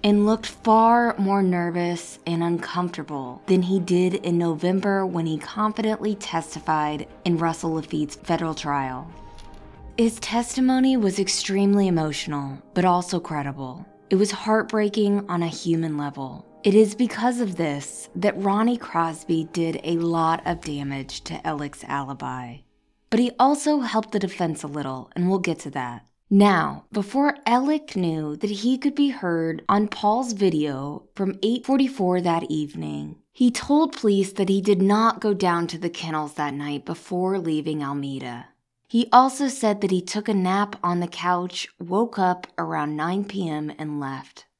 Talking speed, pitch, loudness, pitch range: 155 wpm, 180 Hz, -23 LUFS, 155-210 Hz